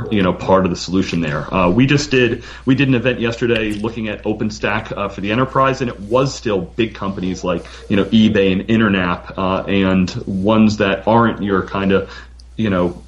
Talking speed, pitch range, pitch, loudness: 205 wpm, 95-115 Hz, 105 Hz, -17 LUFS